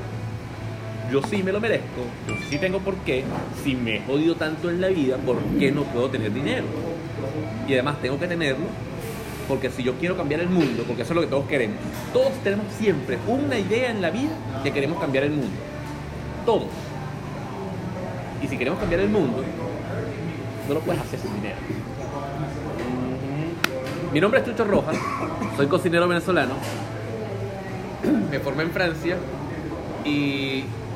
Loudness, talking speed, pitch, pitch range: -25 LUFS, 160 wpm, 135 Hz, 115-160 Hz